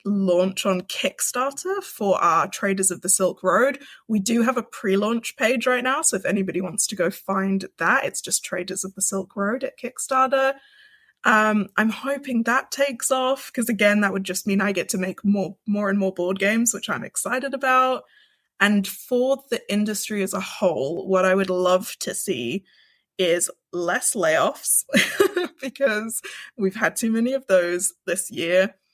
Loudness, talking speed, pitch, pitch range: -22 LUFS, 180 wpm, 210 Hz, 190-260 Hz